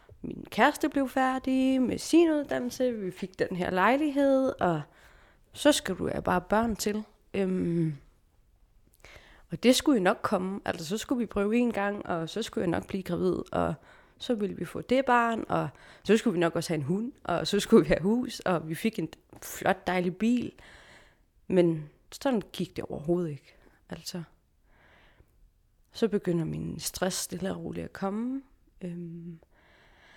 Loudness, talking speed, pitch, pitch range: -28 LUFS, 175 wpm, 200 Hz, 175-245 Hz